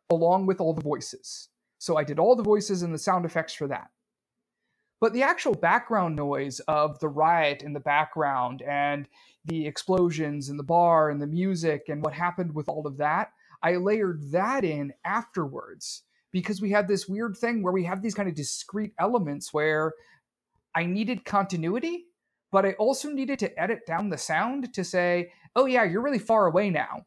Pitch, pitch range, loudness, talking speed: 180 Hz, 155-210 Hz, -26 LUFS, 190 wpm